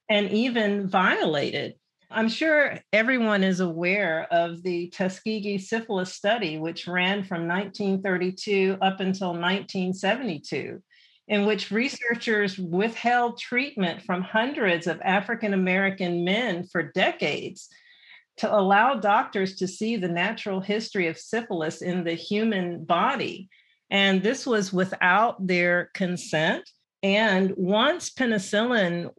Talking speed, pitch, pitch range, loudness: 115 wpm, 195 Hz, 180-220 Hz, -25 LUFS